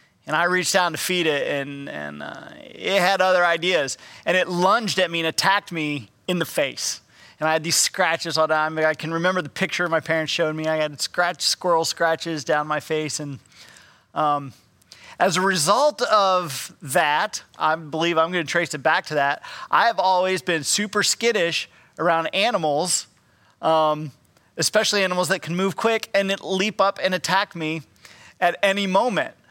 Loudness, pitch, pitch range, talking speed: -21 LUFS, 170 Hz, 155-185 Hz, 190 wpm